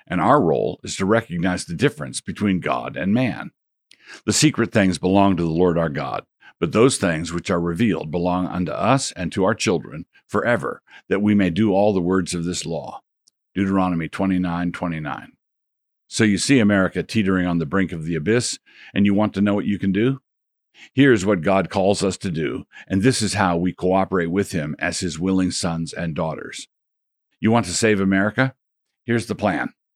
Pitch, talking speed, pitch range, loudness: 95 Hz, 195 wpm, 90-105 Hz, -21 LUFS